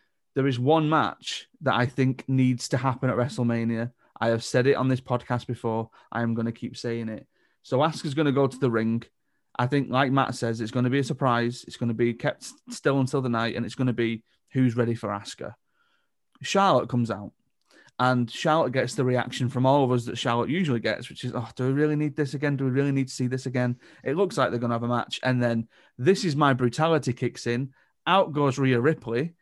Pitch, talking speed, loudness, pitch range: 125 Hz, 245 wpm, -26 LUFS, 120-140 Hz